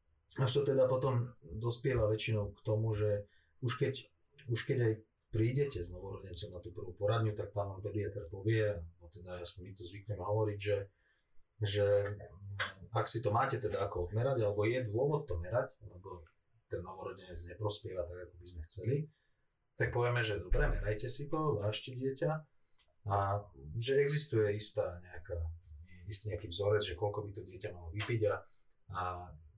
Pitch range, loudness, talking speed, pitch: 90-115 Hz, -36 LUFS, 165 wpm, 105 Hz